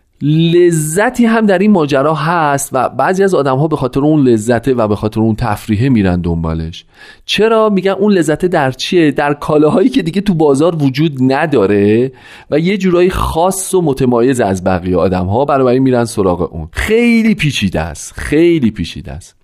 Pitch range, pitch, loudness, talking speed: 110-175 Hz, 140 Hz, -12 LUFS, 175 wpm